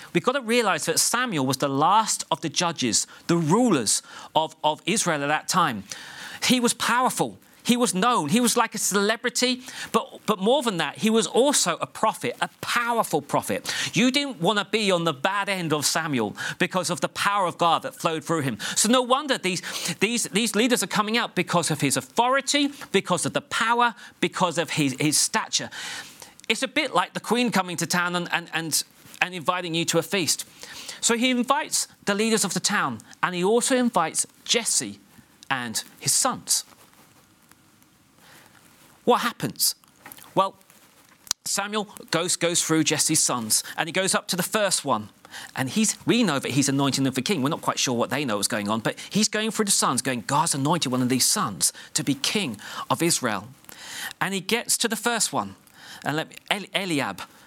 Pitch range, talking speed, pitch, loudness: 160-230 Hz, 195 wpm, 185 Hz, -23 LUFS